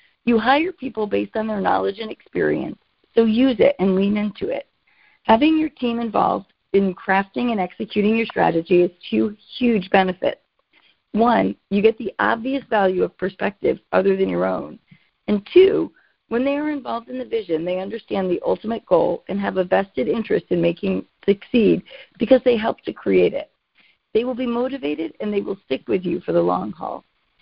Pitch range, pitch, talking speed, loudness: 185-245 Hz, 215 Hz, 185 wpm, -20 LUFS